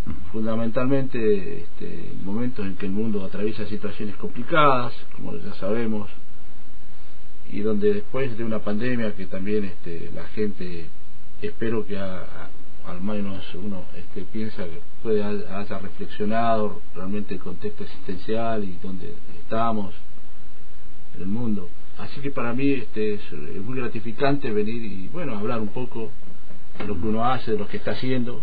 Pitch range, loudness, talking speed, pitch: 100-115 Hz, -28 LUFS, 150 wpm, 105 Hz